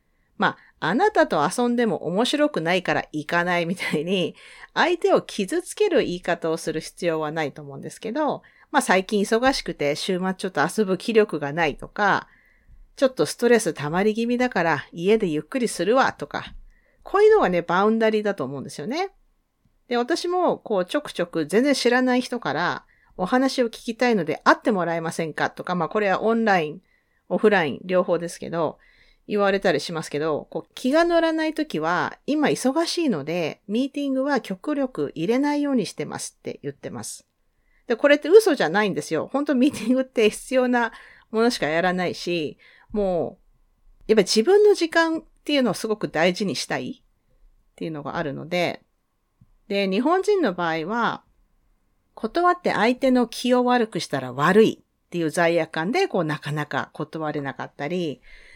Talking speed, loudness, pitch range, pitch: 360 characters per minute, -22 LUFS, 170-265 Hz, 215 Hz